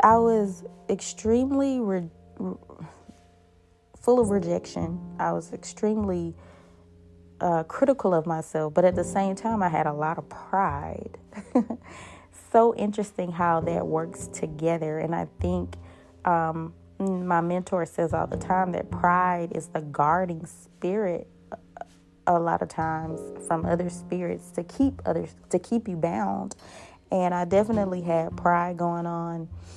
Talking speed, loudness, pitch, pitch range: 140 wpm, -26 LUFS, 175 Hz, 155-185 Hz